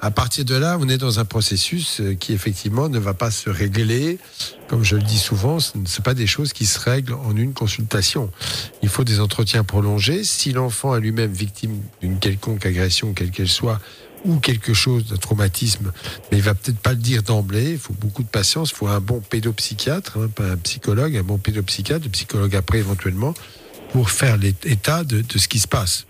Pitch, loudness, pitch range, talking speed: 110 Hz, -20 LUFS, 105-125 Hz, 215 wpm